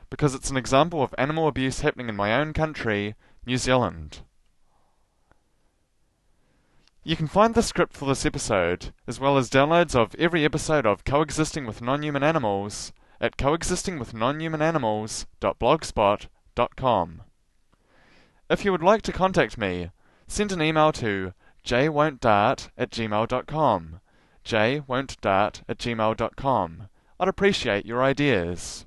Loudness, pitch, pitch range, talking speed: -24 LUFS, 130 Hz, 105-155 Hz, 120 wpm